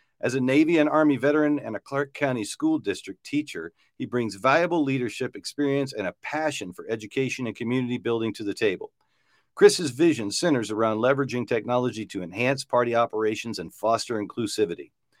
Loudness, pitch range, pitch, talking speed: -25 LUFS, 115-150 Hz, 130 Hz, 165 wpm